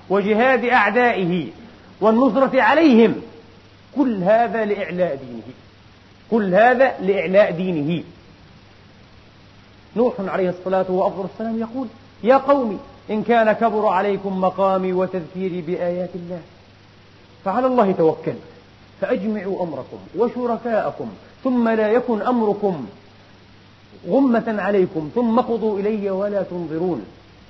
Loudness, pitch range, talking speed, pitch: -19 LUFS, 160-230 Hz, 95 wpm, 195 Hz